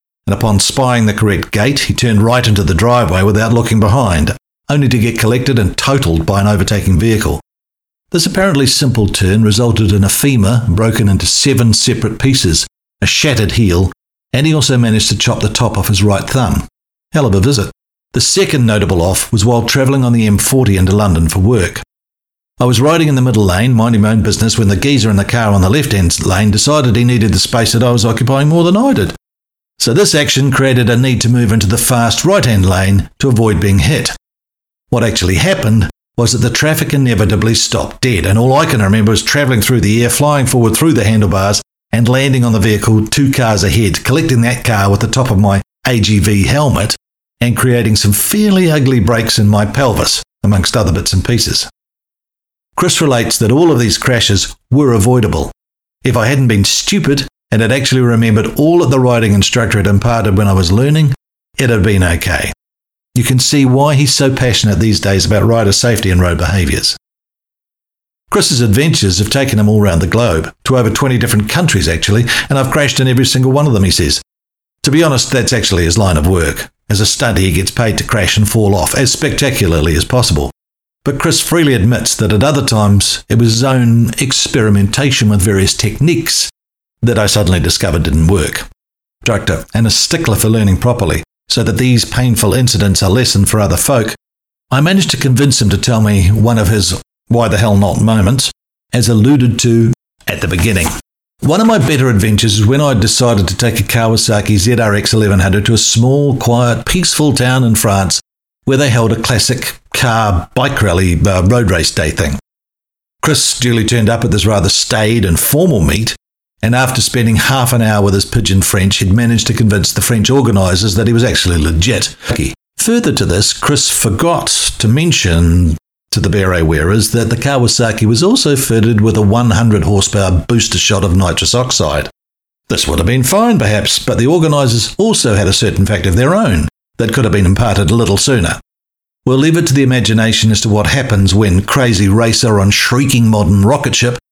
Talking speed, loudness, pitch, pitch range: 200 wpm, -11 LUFS, 115 Hz, 100-125 Hz